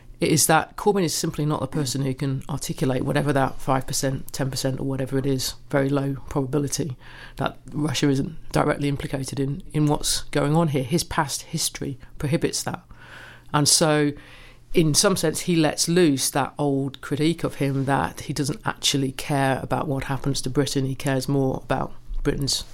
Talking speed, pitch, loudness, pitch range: 175 wpm, 140 Hz, -23 LUFS, 135-150 Hz